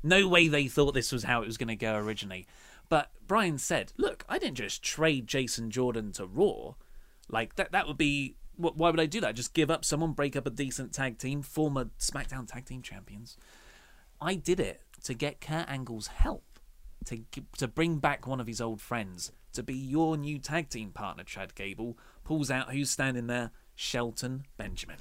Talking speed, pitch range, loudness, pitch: 200 wpm, 115-150 Hz, -31 LUFS, 130 Hz